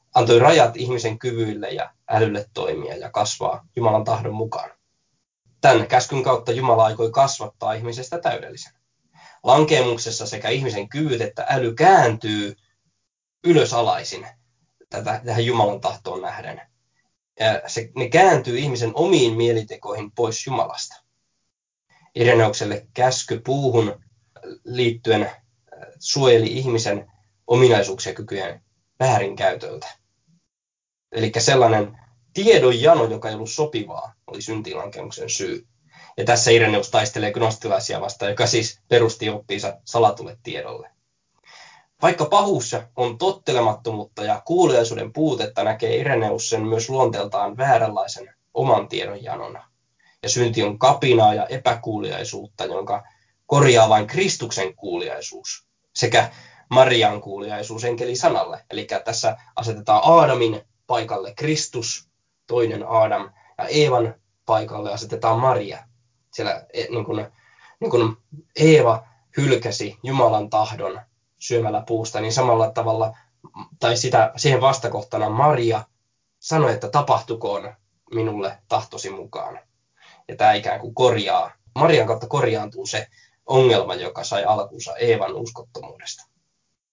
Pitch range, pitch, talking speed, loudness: 110-125 Hz, 115 Hz, 105 wpm, -20 LUFS